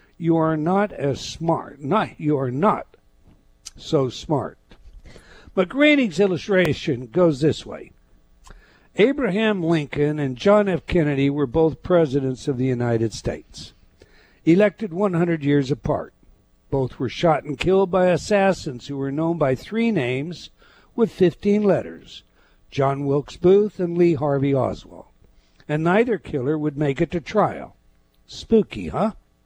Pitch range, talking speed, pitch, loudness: 140-190 Hz, 135 wpm, 160 Hz, -21 LUFS